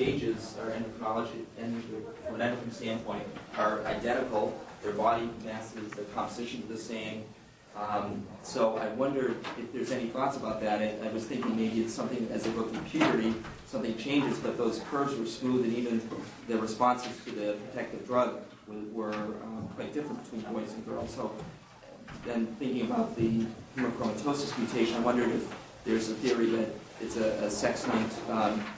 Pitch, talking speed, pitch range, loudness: 115 Hz, 170 wpm, 110-120 Hz, -33 LUFS